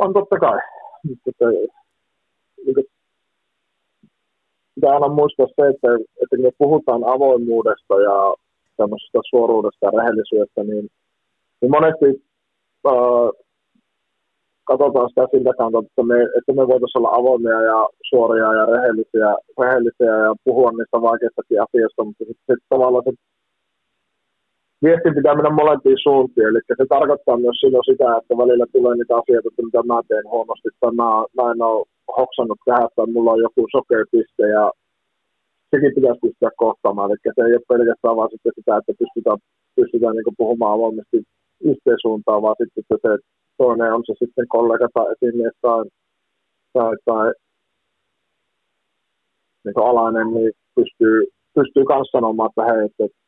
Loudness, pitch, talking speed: -17 LUFS, 125 Hz, 135 wpm